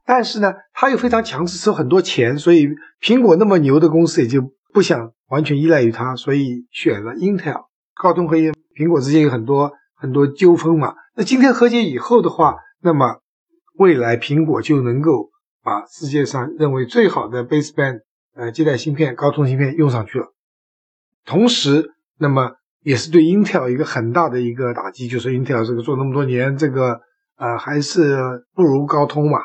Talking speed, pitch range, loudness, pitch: 305 characters per minute, 130-175 Hz, -16 LUFS, 150 Hz